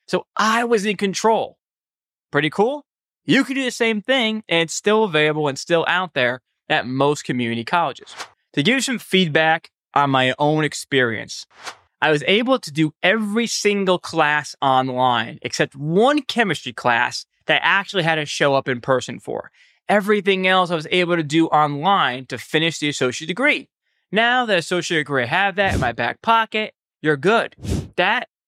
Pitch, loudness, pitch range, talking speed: 170 Hz, -19 LUFS, 145-215 Hz, 175 wpm